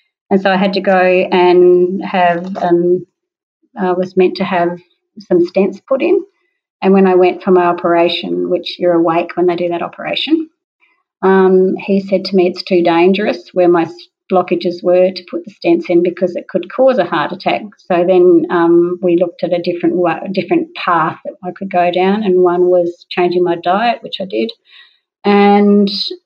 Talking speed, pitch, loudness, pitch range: 190 wpm, 180 Hz, -13 LUFS, 175-195 Hz